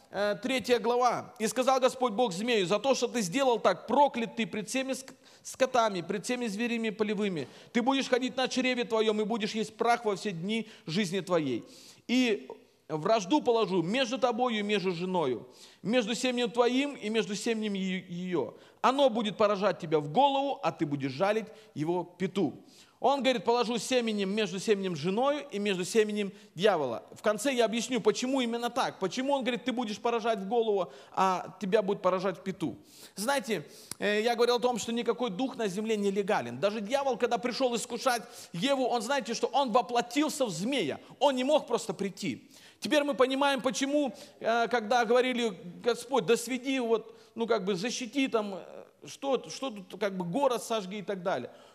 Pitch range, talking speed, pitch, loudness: 205-255 Hz, 175 wpm, 230 Hz, -30 LUFS